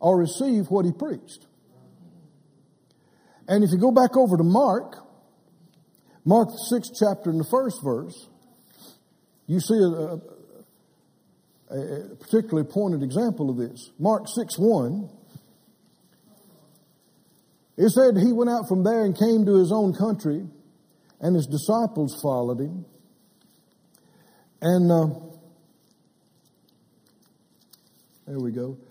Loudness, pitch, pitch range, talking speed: -23 LUFS, 180 Hz, 155-215 Hz, 115 wpm